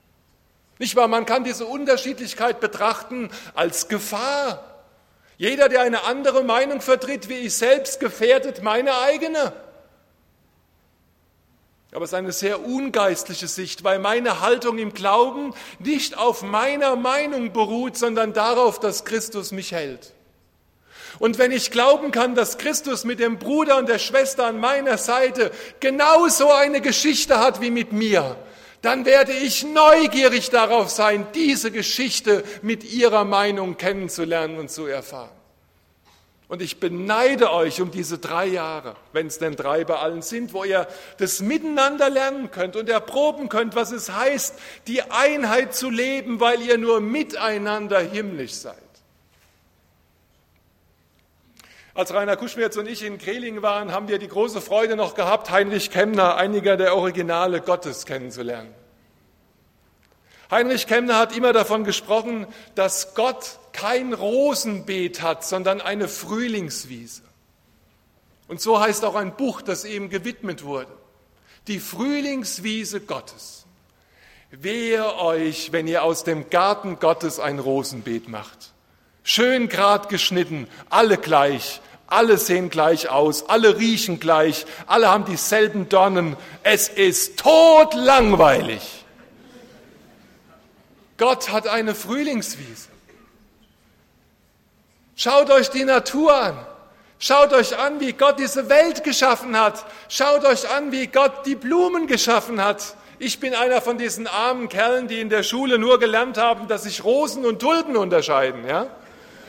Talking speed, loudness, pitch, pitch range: 135 wpm, -20 LUFS, 215 Hz, 180-255 Hz